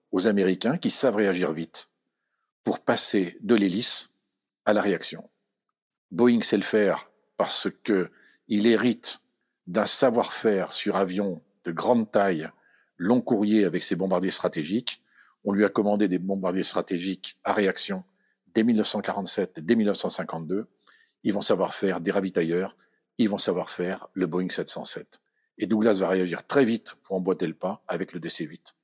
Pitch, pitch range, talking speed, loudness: 100 Hz, 95-115 Hz, 155 wpm, -25 LUFS